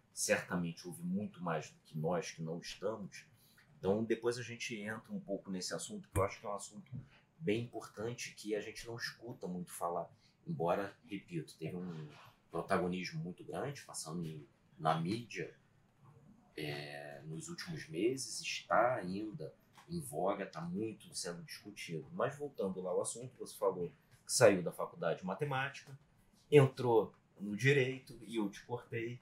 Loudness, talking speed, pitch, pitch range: -38 LUFS, 160 wpm, 120 Hz, 100-150 Hz